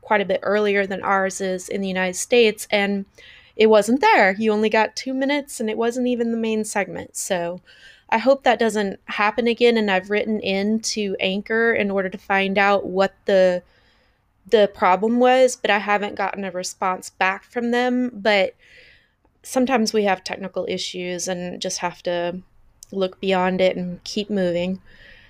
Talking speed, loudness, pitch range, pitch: 180 wpm, -20 LUFS, 185-225 Hz, 200 Hz